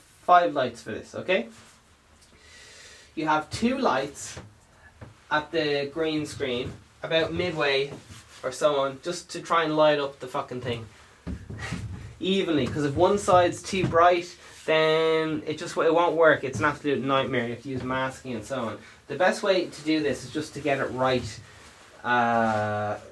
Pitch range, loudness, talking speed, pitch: 115-160 Hz, -25 LUFS, 170 wpm, 140 Hz